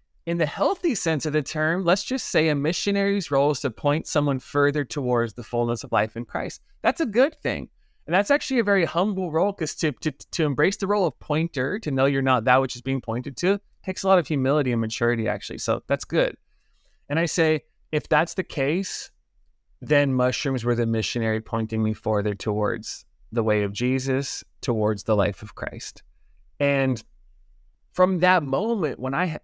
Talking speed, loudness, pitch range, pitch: 200 wpm, -24 LUFS, 120-170 Hz, 140 Hz